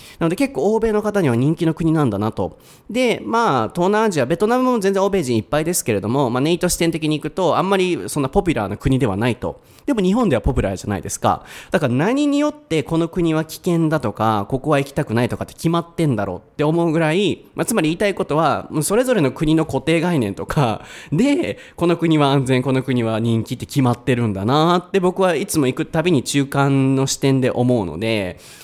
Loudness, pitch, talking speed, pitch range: -19 LUFS, 155 Hz, 445 characters per minute, 130-180 Hz